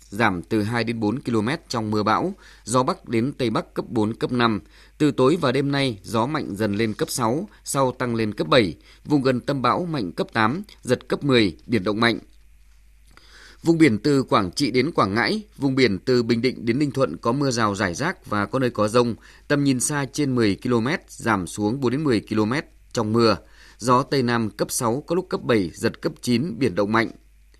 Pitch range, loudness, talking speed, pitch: 110-135 Hz, -22 LUFS, 220 wpm, 120 Hz